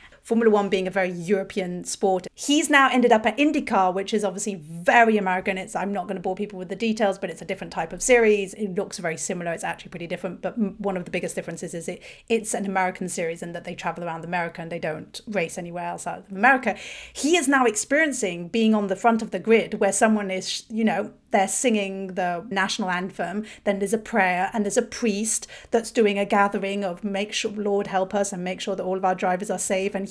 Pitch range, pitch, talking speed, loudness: 185-220 Hz, 195 Hz, 240 wpm, -24 LUFS